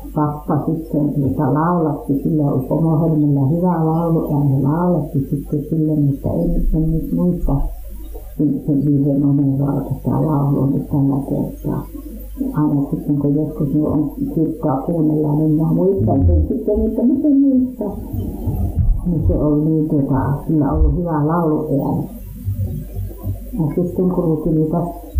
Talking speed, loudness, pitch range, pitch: 105 wpm, -18 LUFS, 140-160 Hz, 150 Hz